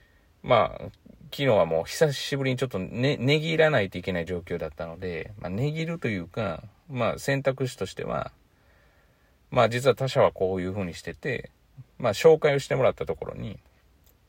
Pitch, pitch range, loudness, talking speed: 115 Hz, 90-140 Hz, -26 LUFS, 355 characters per minute